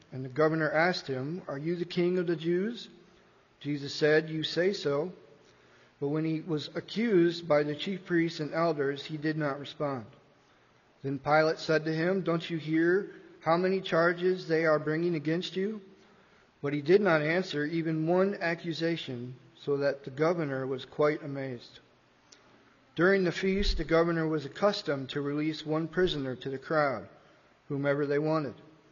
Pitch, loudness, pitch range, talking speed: 160 Hz, -30 LUFS, 145-175 Hz, 165 wpm